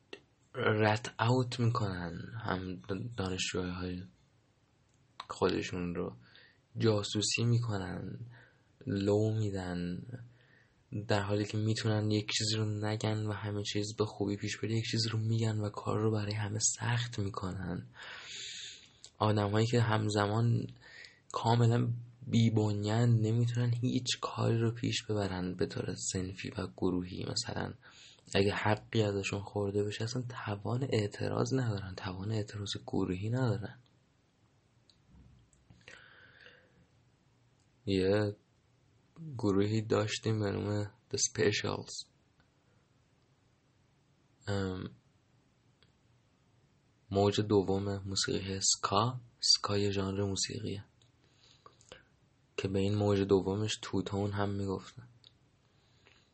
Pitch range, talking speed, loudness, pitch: 100-120 Hz, 95 wpm, -33 LUFS, 105 Hz